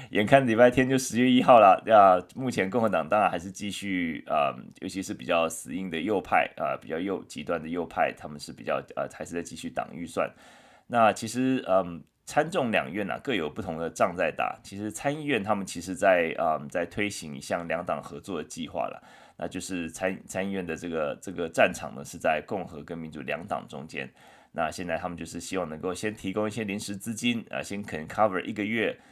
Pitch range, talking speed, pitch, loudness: 85-110 Hz, 335 characters per minute, 95 Hz, -27 LUFS